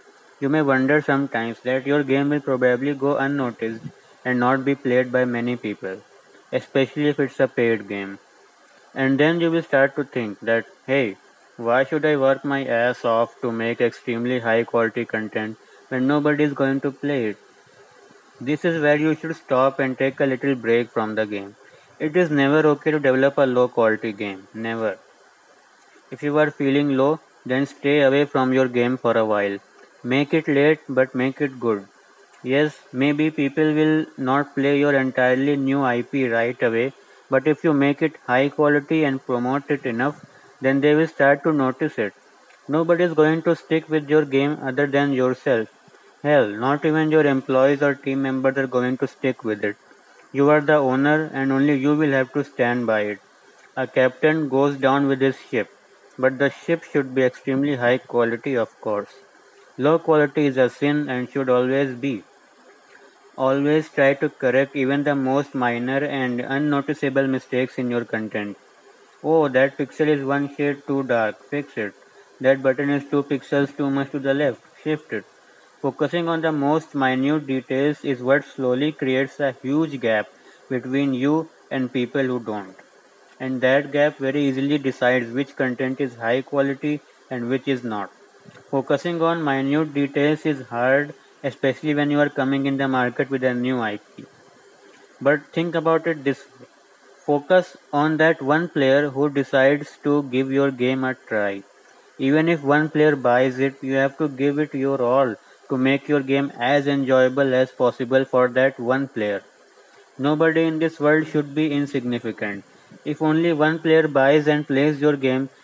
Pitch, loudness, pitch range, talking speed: 135 Hz, -21 LUFS, 130-145 Hz, 175 wpm